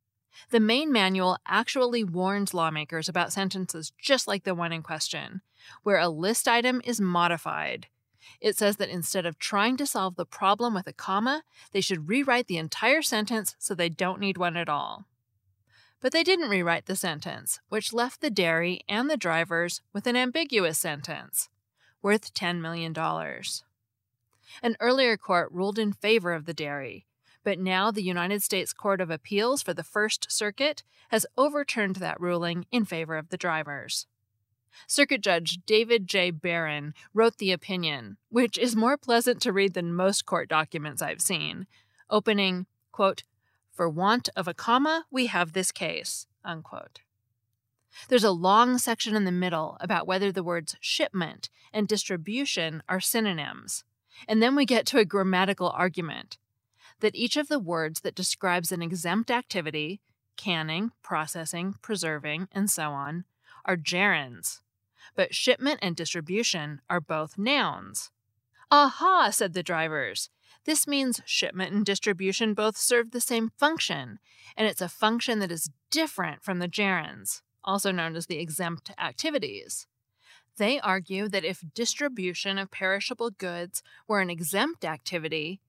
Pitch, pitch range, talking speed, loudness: 190 Hz, 165-220 Hz, 155 wpm, -27 LUFS